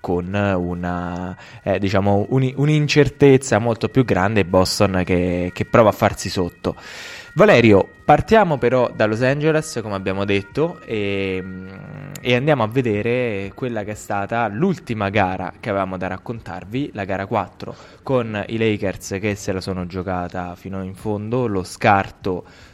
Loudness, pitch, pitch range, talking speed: -19 LUFS, 100 Hz, 95-125 Hz, 145 wpm